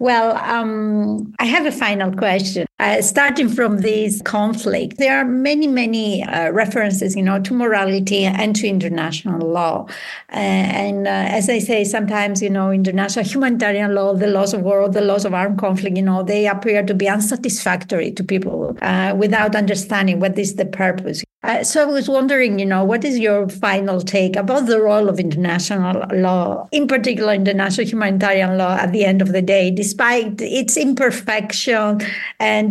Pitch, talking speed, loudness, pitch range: 205 Hz, 175 wpm, -17 LUFS, 195-225 Hz